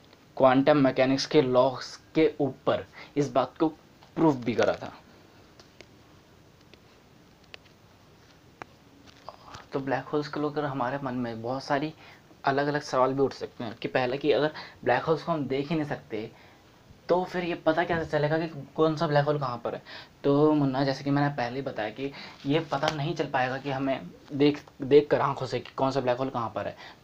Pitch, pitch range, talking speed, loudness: 140 Hz, 135-155 Hz, 190 wpm, -27 LUFS